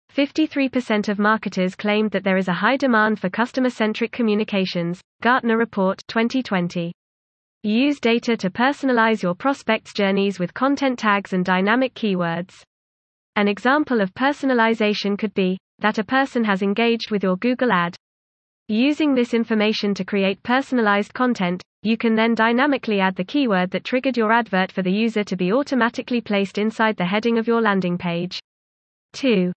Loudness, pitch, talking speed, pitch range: -20 LUFS, 215 Hz, 160 wpm, 185-240 Hz